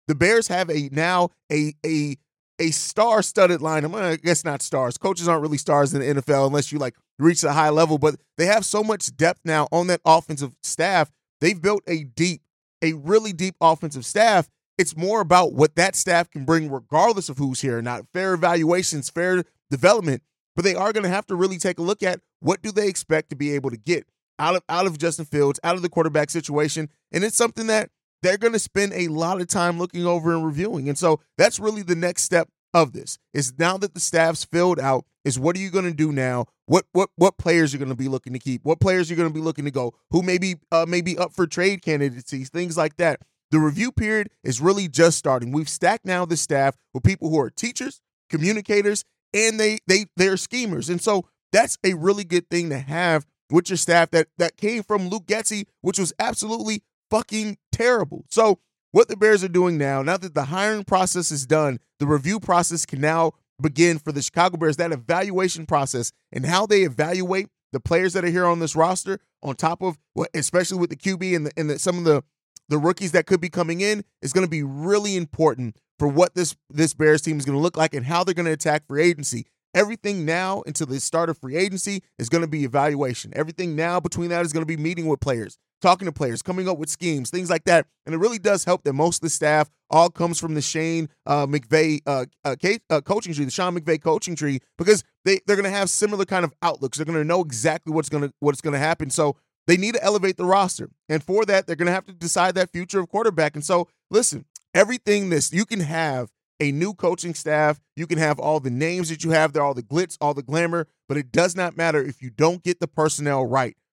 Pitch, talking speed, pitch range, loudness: 170 Hz, 235 wpm, 150-185 Hz, -22 LUFS